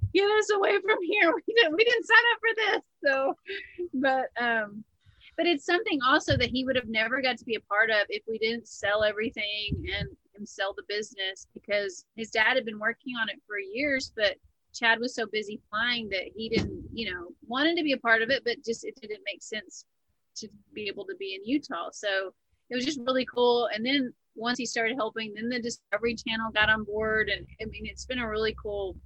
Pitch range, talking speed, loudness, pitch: 215-280 Hz, 225 wpm, -27 LUFS, 230 Hz